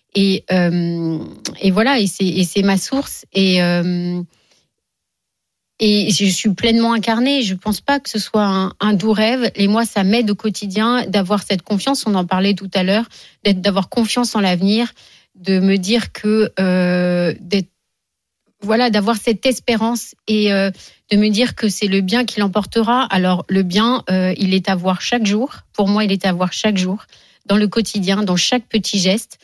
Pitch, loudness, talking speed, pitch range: 200 Hz, -17 LUFS, 190 wpm, 185-220 Hz